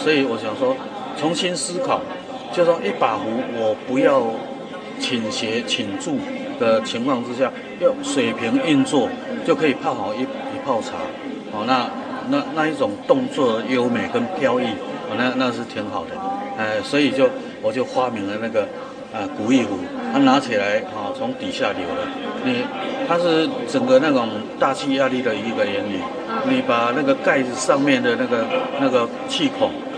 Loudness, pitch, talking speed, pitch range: -21 LUFS, 265 Hz, 240 characters per minute, 260-270 Hz